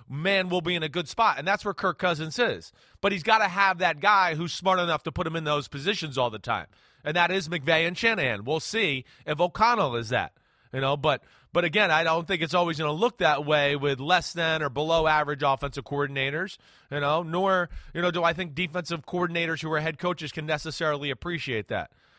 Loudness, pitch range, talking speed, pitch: -26 LUFS, 145-180 Hz, 230 wpm, 165 Hz